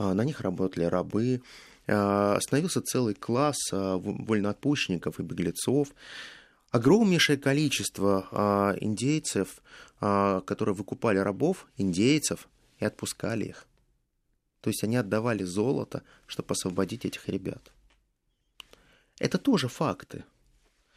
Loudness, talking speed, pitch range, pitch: -28 LUFS, 90 wpm, 95-125 Hz, 105 Hz